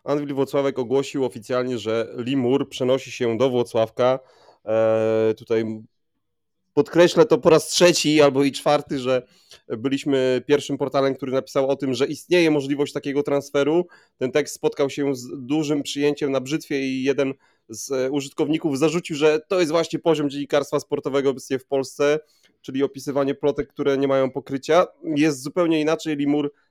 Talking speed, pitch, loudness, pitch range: 155 wpm, 140 Hz, -22 LUFS, 130-150 Hz